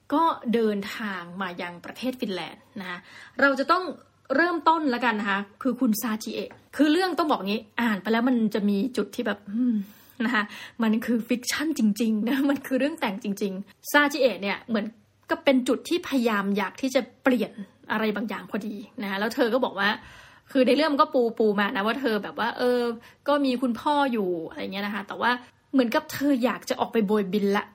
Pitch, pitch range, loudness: 235 Hz, 210-265 Hz, -25 LUFS